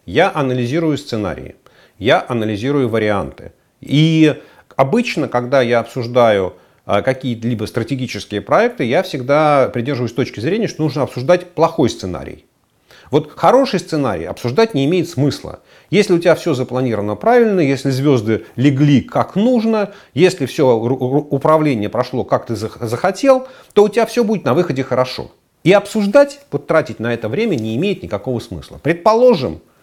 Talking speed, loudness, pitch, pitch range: 140 wpm, -16 LUFS, 140 Hz, 120-180 Hz